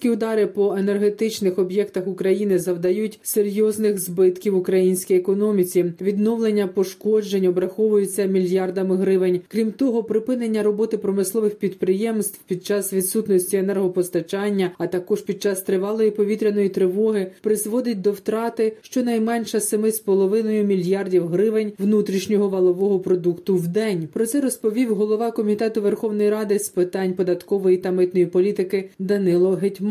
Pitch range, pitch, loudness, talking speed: 190-215 Hz, 200 Hz, -21 LUFS, 120 wpm